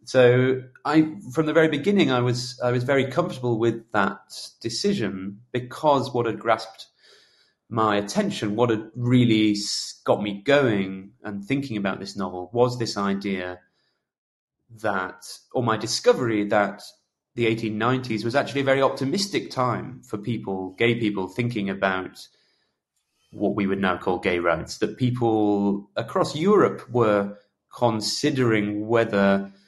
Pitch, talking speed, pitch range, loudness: 110 Hz, 135 wpm, 100-125 Hz, -23 LUFS